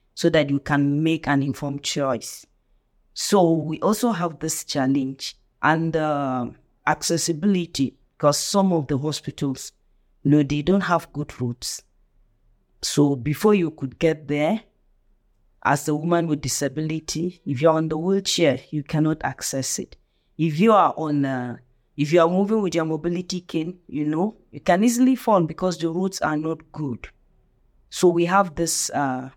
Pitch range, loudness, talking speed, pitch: 140-175 Hz, -22 LUFS, 165 wpm, 155 Hz